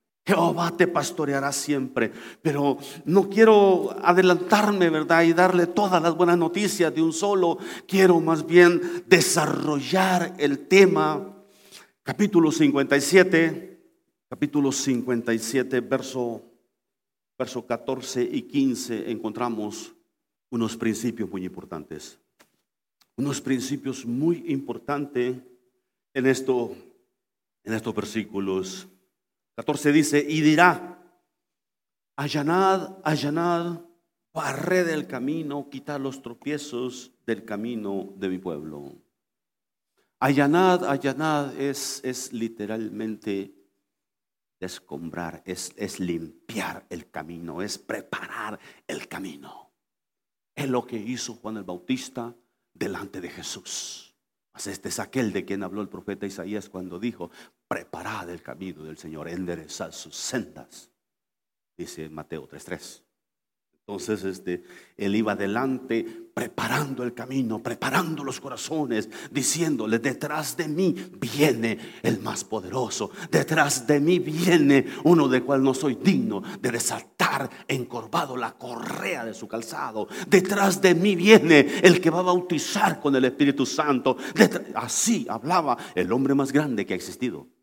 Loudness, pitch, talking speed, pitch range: -24 LUFS, 140 Hz, 115 wpm, 115-170 Hz